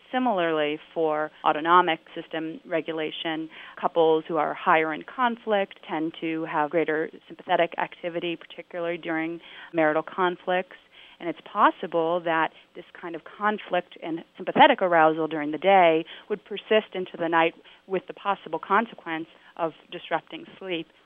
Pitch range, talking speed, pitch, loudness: 160-185 Hz, 135 wpm, 170 Hz, -25 LUFS